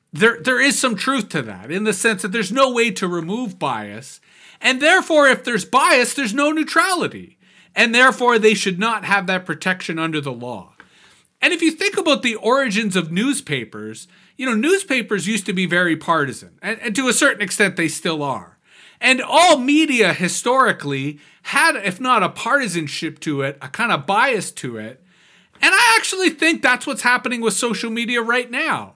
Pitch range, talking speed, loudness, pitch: 175-260 Hz, 190 wpm, -17 LUFS, 220 Hz